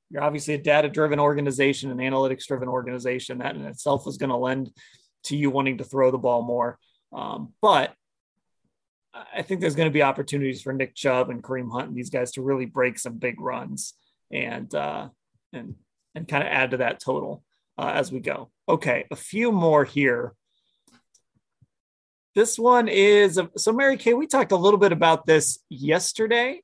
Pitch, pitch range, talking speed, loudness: 140 Hz, 130-165 Hz, 180 wpm, -23 LUFS